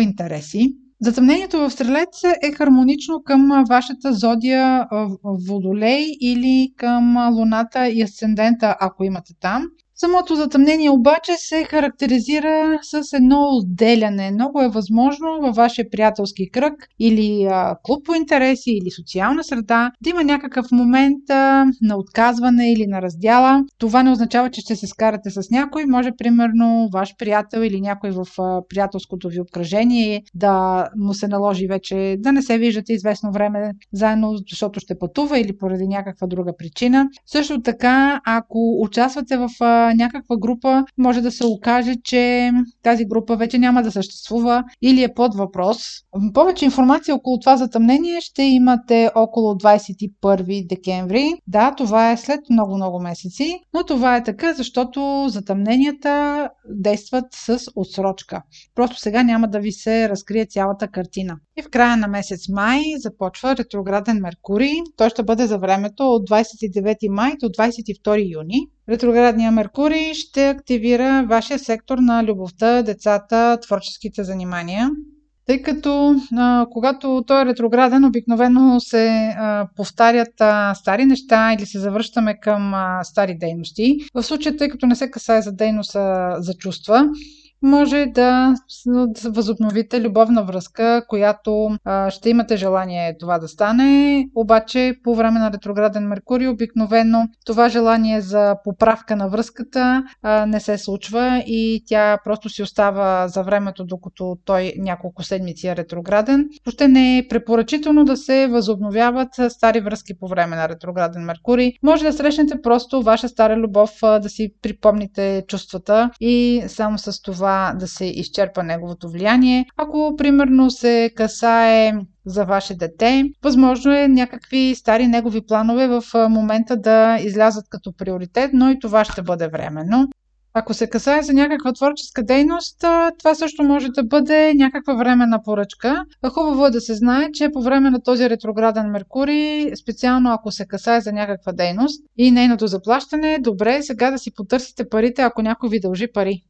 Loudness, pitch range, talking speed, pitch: -17 LUFS, 205-260 Hz, 145 wpm, 230 Hz